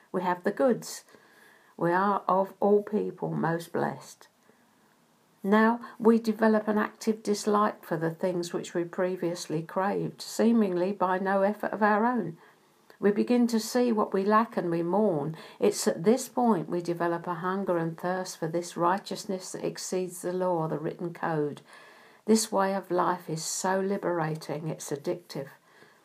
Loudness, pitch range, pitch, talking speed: -28 LUFS, 175-210 Hz, 190 Hz, 160 wpm